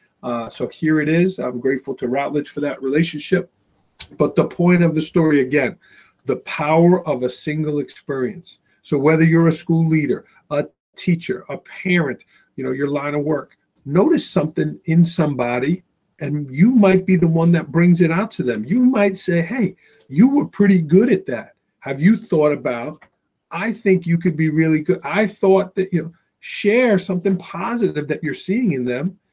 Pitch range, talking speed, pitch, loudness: 150-190 Hz, 185 wpm, 170 Hz, -18 LUFS